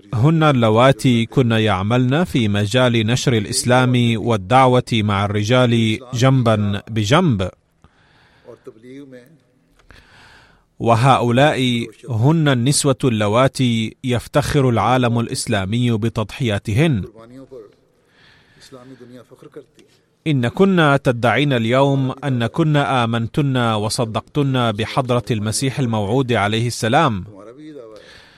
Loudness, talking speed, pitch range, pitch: -17 LUFS, 70 wpm, 115-135 Hz, 125 Hz